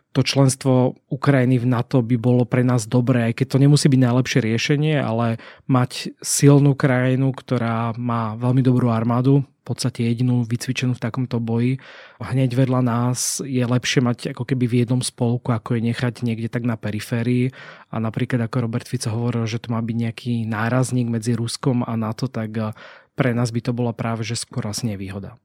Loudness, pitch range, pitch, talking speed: -20 LUFS, 115-130 Hz, 125 Hz, 180 wpm